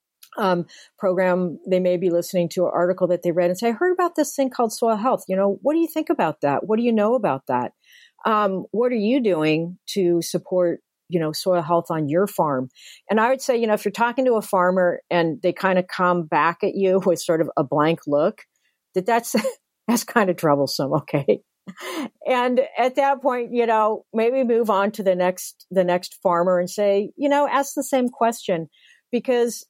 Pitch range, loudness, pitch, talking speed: 175-240 Hz, -21 LUFS, 195 Hz, 215 wpm